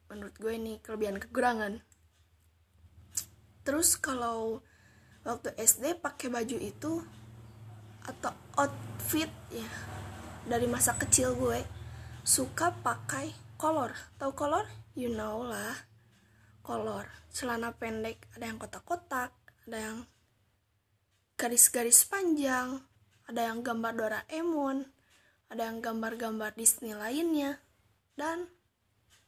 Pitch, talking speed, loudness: 225 Hz, 95 wpm, -31 LUFS